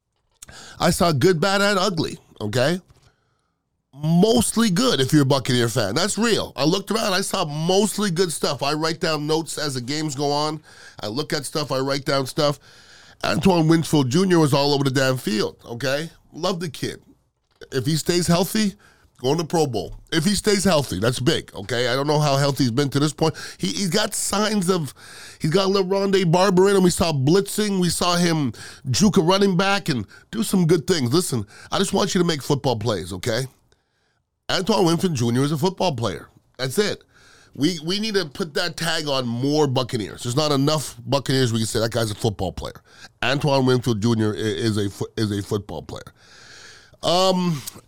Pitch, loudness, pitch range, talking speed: 155 Hz, -21 LUFS, 130-185 Hz, 200 wpm